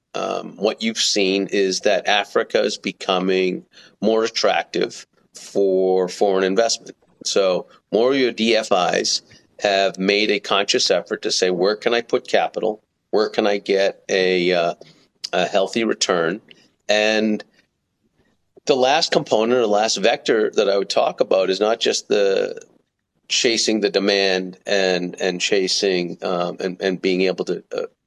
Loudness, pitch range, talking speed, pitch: -19 LUFS, 95-110 Hz, 150 wpm, 100 Hz